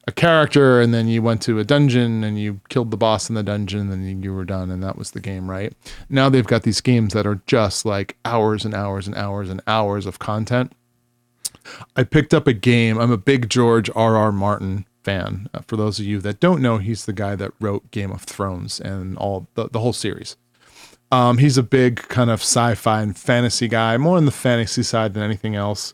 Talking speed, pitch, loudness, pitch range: 225 wpm, 110 Hz, -19 LUFS, 100-120 Hz